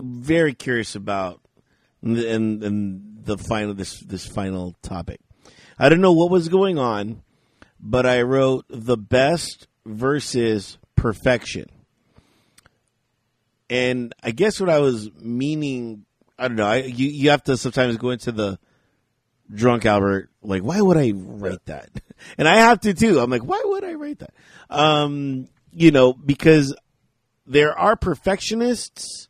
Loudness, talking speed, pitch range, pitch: -20 LUFS, 145 wpm, 110-150 Hz, 125 Hz